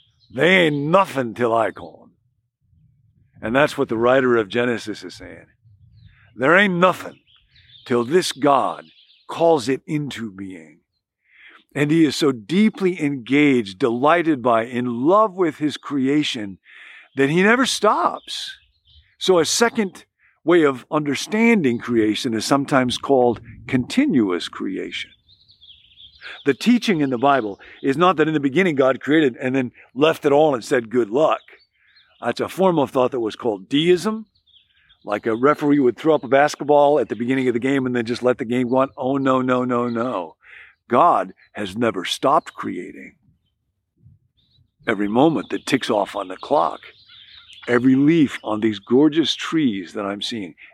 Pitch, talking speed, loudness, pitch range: 135 Hz, 160 wpm, -19 LUFS, 120-155 Hz